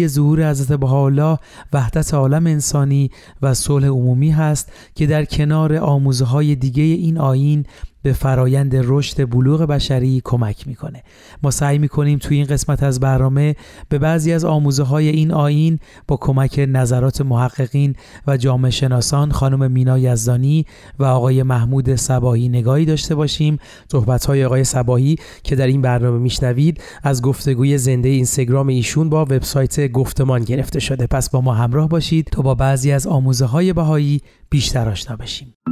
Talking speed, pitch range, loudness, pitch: 155 wpm, 130-150 Hz, -16 LUFS, 135 Hz